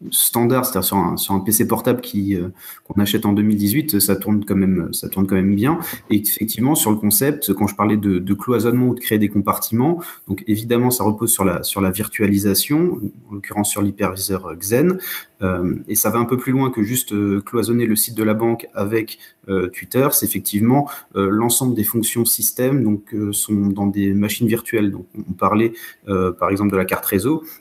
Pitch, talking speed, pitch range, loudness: 105 Hz, 215 wpm, 100-120 Hz, -18 LUFS